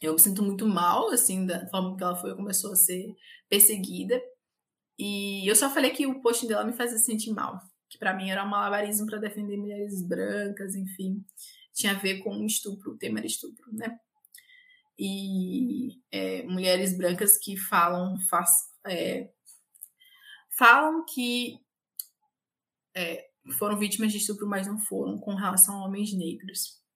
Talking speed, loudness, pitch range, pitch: 160 wpm, -26 LUFS, 190-235 Hz, 205 Hz